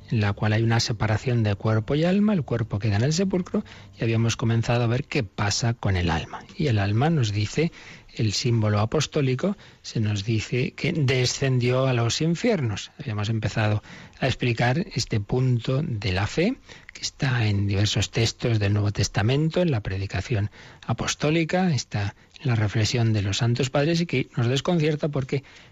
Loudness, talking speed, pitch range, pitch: -24 LUFS, 175 wpm, 105-145 Hz, 120 Hz